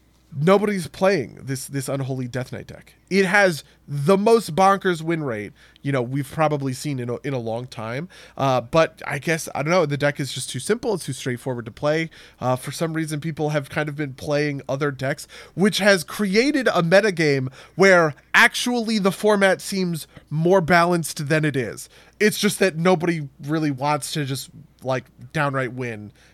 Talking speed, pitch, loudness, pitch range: 185 wpm, 150 Hz, -21 LUFS, 135-185 Hz